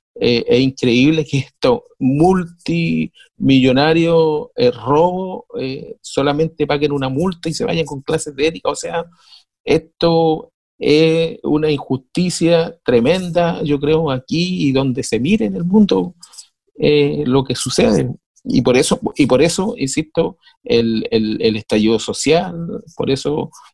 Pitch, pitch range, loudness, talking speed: 155 Hz, 135-170 Hz, -16 LUFS, 140 wpm